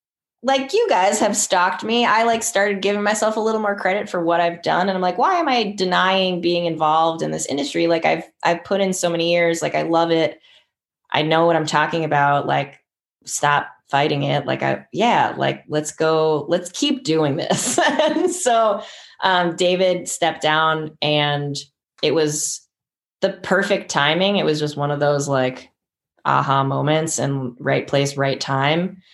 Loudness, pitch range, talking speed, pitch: -19 LUFS, 150-195 Hz, 185 wpm, 170 Hz